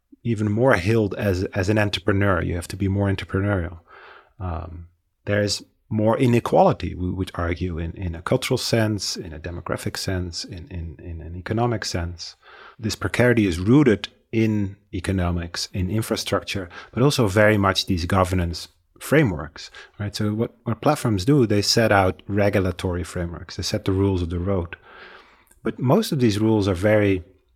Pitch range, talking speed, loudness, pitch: 90-110 Hz, 165 wpm, -22 LUFS, 100 Hz